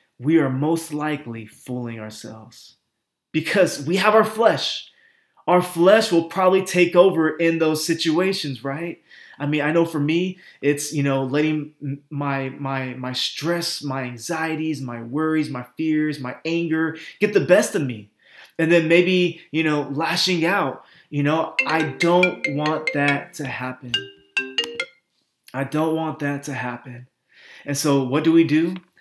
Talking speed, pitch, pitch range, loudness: 155 wpm, 155 Hz, 135-170 Hz, -21 LUFS